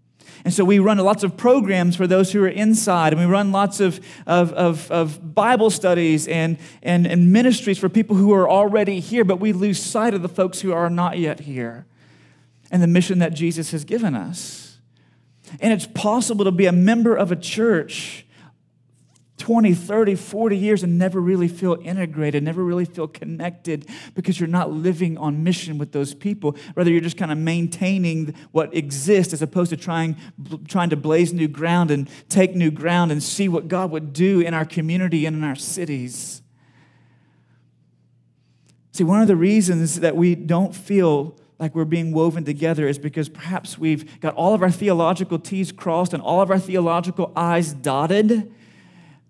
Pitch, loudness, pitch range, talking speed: 175 Hz, -20 LUFS, 160-190 Hz, 185 wpm